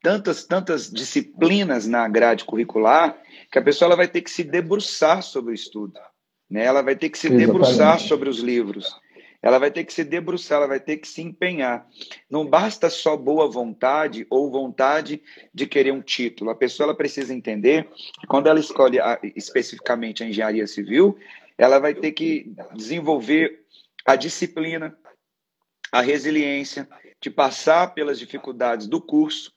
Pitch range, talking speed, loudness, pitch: 125-165 Hz, 160 wpm, -20 LUFS, 145 Hz